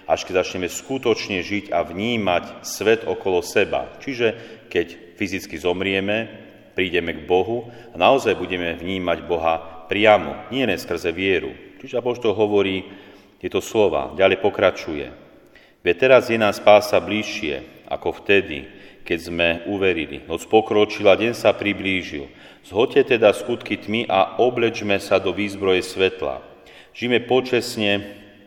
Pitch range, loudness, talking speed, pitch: 90-110 Hz, -20 LUFS, 130 wpm, 100 Hz